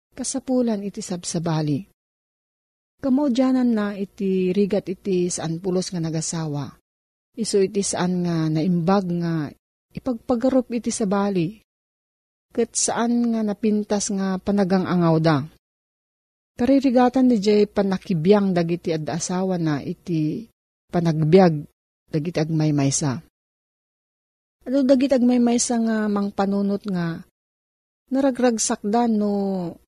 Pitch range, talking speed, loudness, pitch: 170-230 Hz, 100 wpm, -22 LUFS, 200 Hz